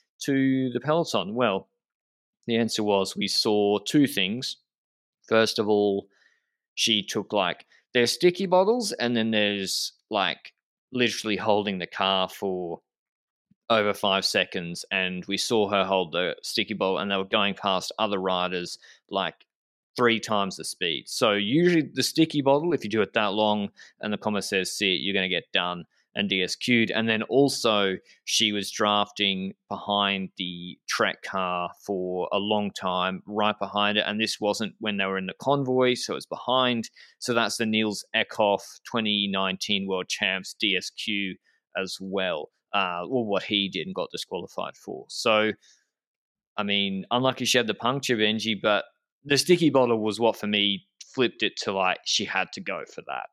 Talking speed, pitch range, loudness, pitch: 170 wpm, 95-120 Hz, -25 LUFS, 105 Hz